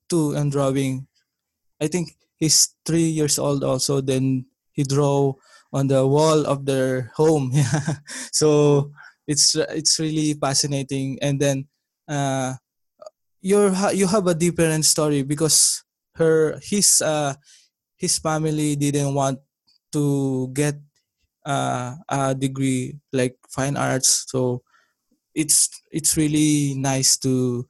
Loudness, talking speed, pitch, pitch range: -20 LUFS, 115 wpm, 145 Hz, 135-155 Hz